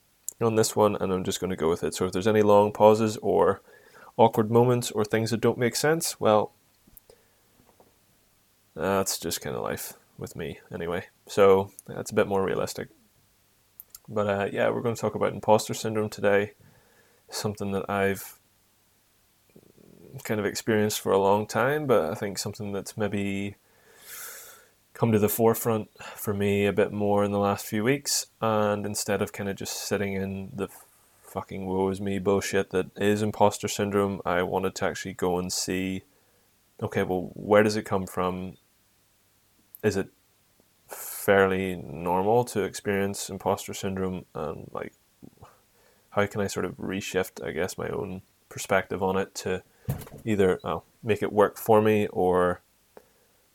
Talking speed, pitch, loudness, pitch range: 165 wpm, 100 Hz, -26 LUFS, 95-110 Hz